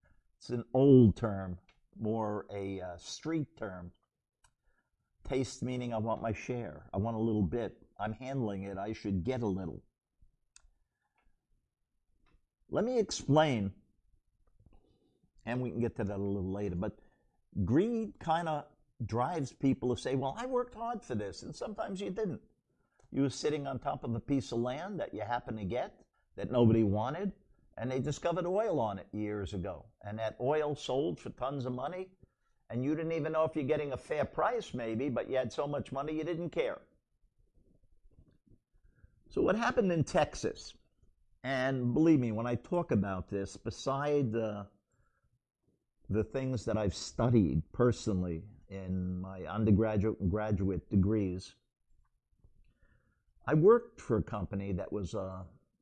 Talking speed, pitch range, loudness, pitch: 160 wpm, 100-140 Hz, -34 LUFS, 115 Hz